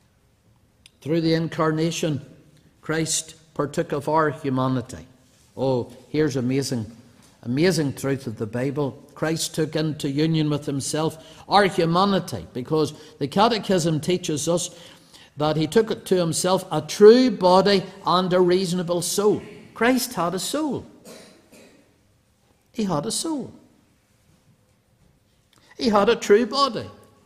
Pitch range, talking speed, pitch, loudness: 140-185 Hz, 120 wpm, 160 Hz, -22 LUFS